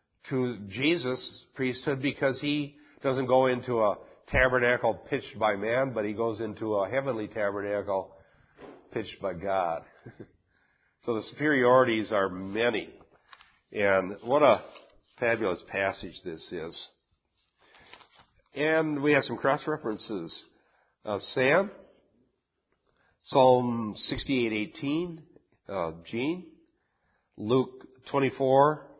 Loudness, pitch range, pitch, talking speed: -28 LUFS, 105-140 Hz, 125 Hz, 105 wpm